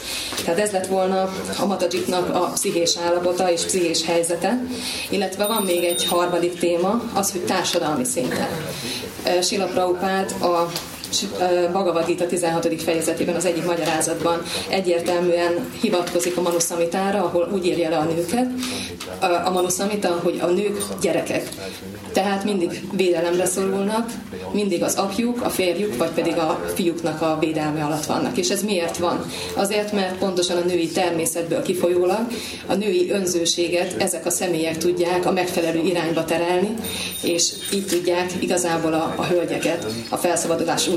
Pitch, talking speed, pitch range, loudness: 175 Hz, 140 wpm, 170-190 Hz, -21 LUFS